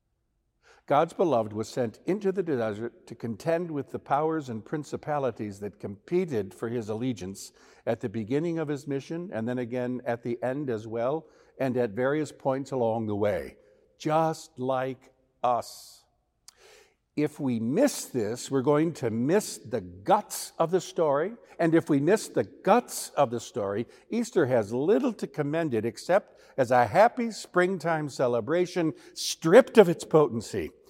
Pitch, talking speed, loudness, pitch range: 135 Hz, 155 wpm, -27 LUFS, 120-165 Hz